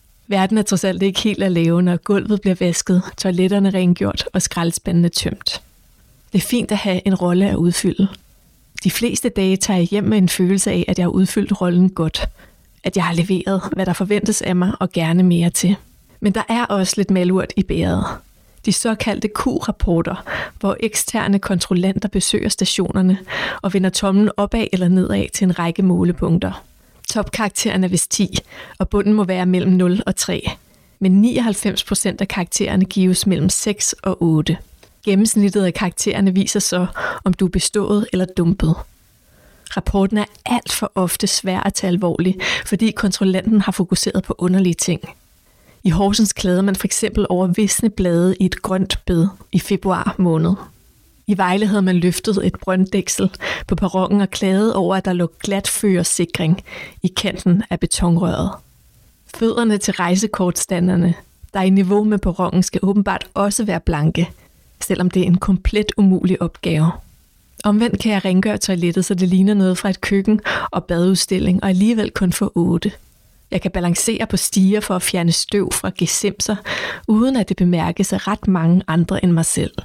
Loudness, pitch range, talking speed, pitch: -17 LUFS, 180-205 Hz, 170 wpm, 190 Hz